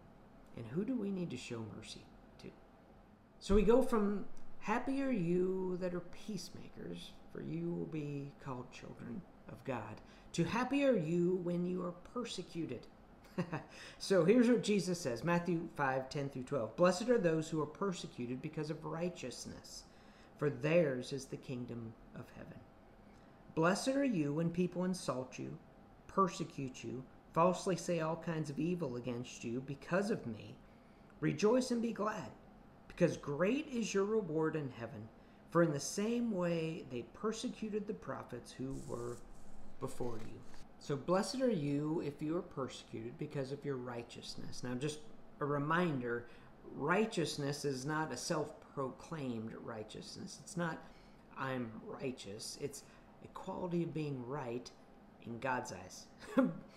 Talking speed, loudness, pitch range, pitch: 150 wpm, -38 LUFS, 135-185 Hz, 160 Hz